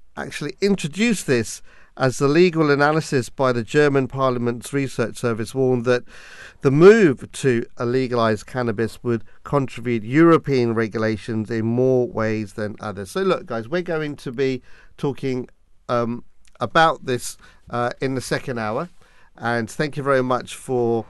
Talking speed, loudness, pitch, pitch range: 150 wpm, -21 LUFS, 125 Hz, 115-145 Hz